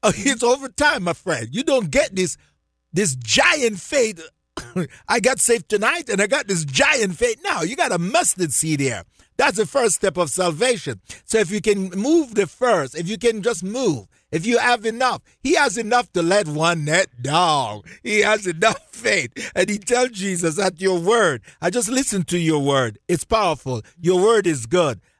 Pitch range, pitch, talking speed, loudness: 165-240 Hz, 195 Hz, 195 wpm, -19 LUFS